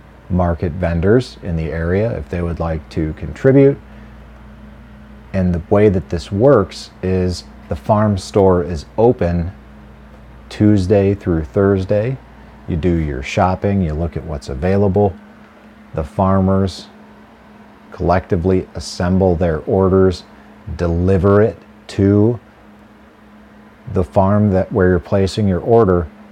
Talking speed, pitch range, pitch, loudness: 120 wpm, 85-105 Hz, 95 Hz, -16 LUFS